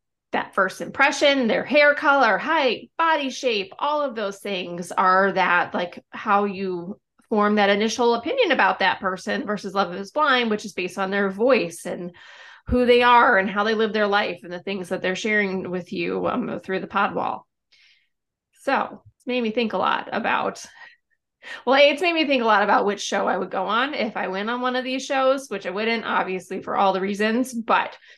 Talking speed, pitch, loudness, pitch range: 205 wpm, 210 Hz, -21 LUFS, 190-260 Hz